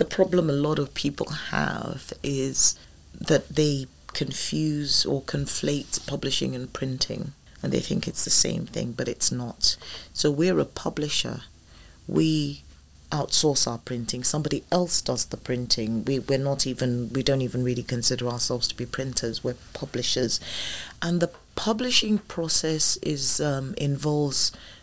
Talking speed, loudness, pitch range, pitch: 145 wpm, -24 LUFS, 120-150 Hz, 135 Hz